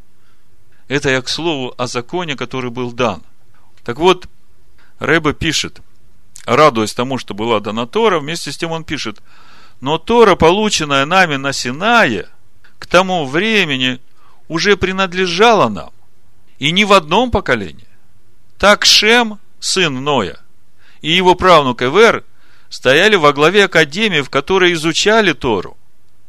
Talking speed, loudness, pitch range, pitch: 130 wpm, -13 LUFS, 115-185 Hz, 145 Hz